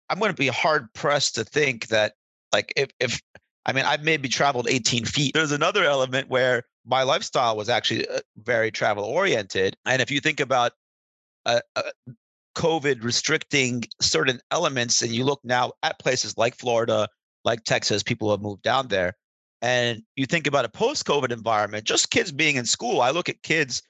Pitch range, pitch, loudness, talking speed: 115-145 Hz, 125 Hz, -23 LUFS, 180 wpm